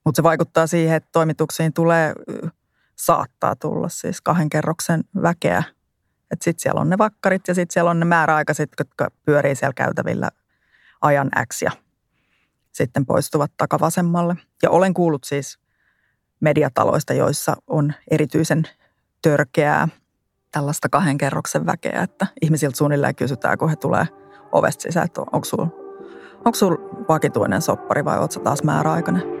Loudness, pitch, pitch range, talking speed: -20 LUFS, 160 Hz, 150-175 Hz, 135 wpm